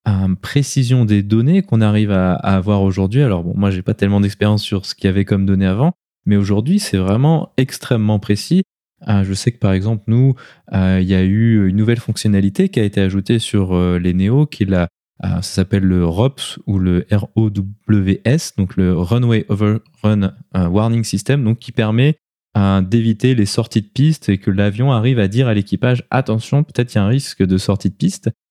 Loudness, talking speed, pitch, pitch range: -16 LUFS, 210 wpm, 105 Hz, 95-120 Hz